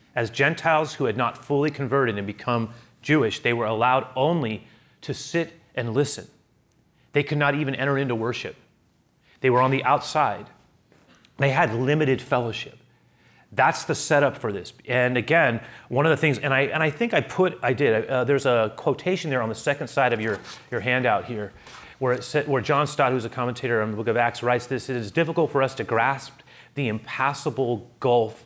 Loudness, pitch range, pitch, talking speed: -24 LUFS, 120-145 Hz, 130 Hz, 200 wpm